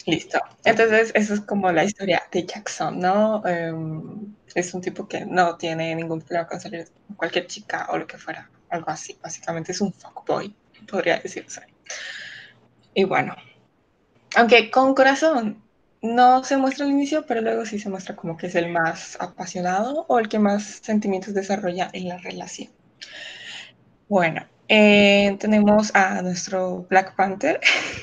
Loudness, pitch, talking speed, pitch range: -21 LUFS, 195 Hz, 155 wpm, 180-220 Hz